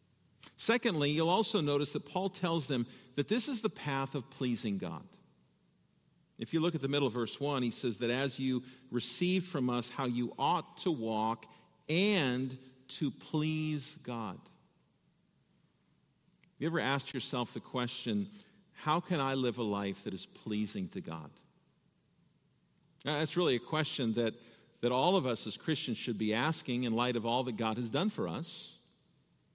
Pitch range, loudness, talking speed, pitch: 120-165 Hz, -34 LUFS, 175 wpm, 140 Hz